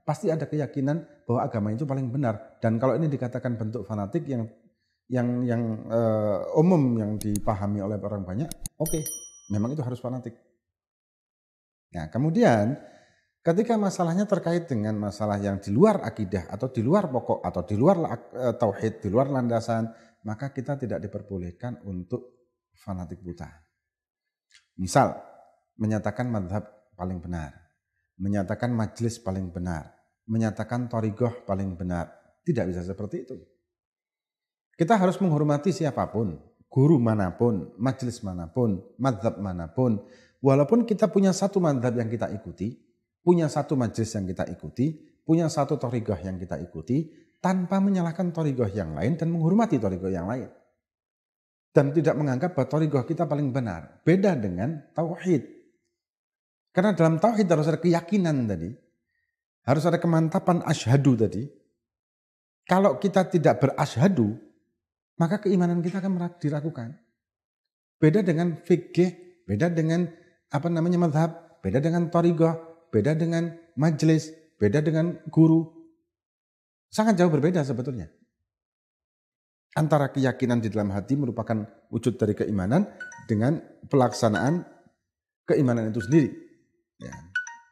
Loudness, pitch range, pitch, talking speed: -26 LUFS, 105-165 Hz, 130 Hz, 125 wpm